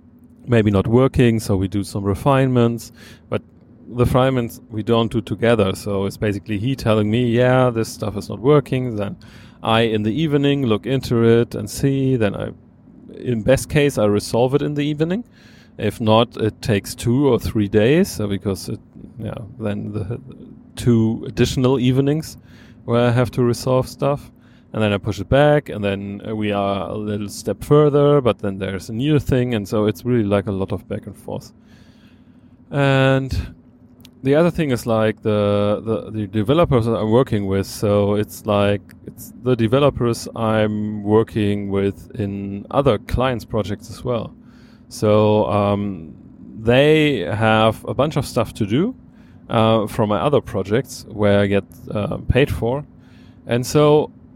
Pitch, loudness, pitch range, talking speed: 115 Hz, -19 LUFS, 105-125 Hz, 170 wpm